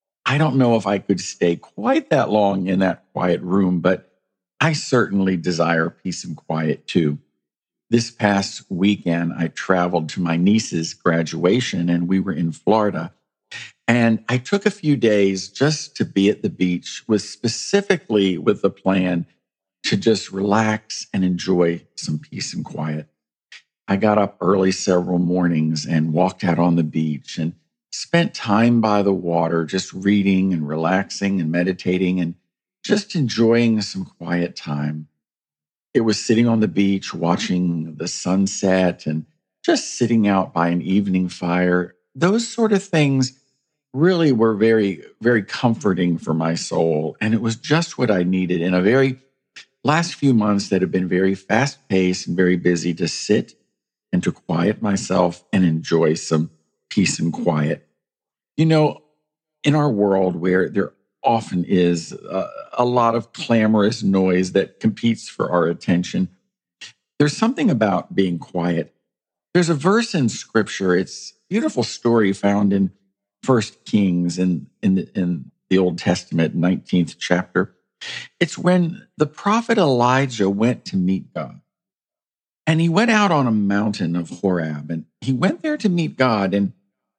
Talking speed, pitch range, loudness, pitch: 155 wpm, 90-120 Hz, -20 LUFS, 95 Hz